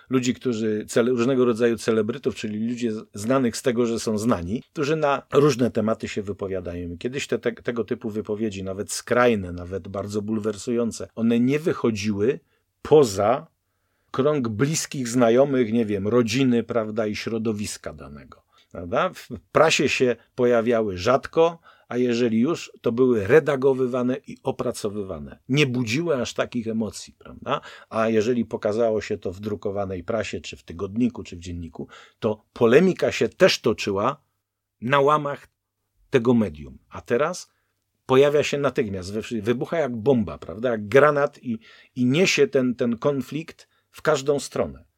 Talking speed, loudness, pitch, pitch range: 145 wpm, -23 LUFS, 115 Hz, 105-130 Hz